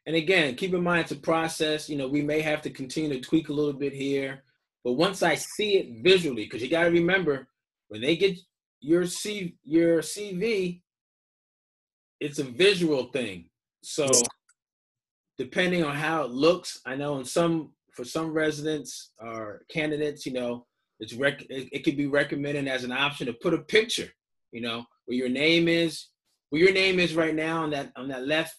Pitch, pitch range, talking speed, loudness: 155 Hz, 140-170 Hz, 190 wpm, -26 LUFS